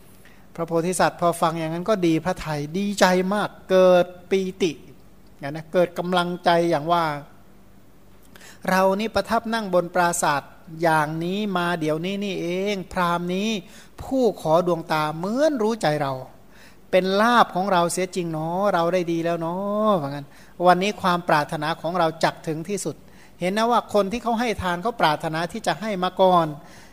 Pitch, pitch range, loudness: 180 Hz, 165-195 Hz, -22 LUFS